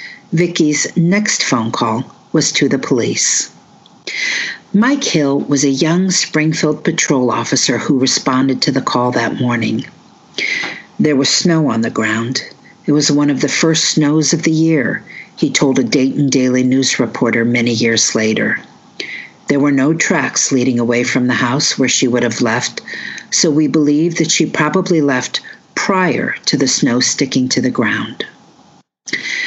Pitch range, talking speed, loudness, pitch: 125-160 Hz, 160 wpm, -14 LUFS, 145 Hz